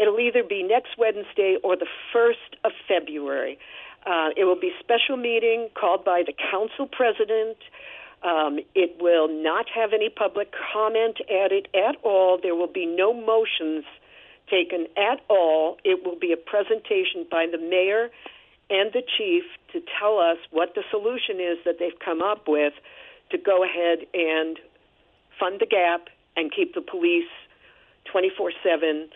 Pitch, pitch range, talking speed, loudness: 200 Hz, 170-250 Hz, 155 wpm, -23 LUFS